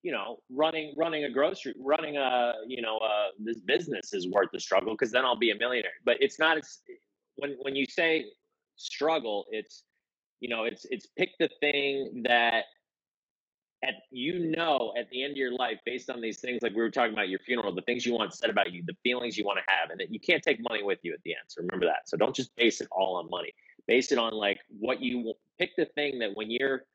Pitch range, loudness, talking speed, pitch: 120-160 Hz, -29 LUFS, 245 wpm, 135 Hz